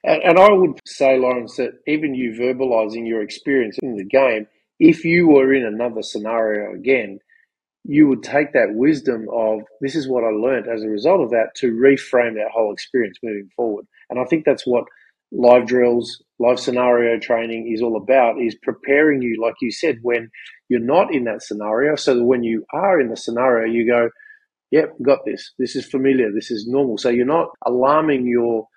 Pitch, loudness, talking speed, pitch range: 120 Hz, -18 LUFS, 195 wpm, 115-135 Hz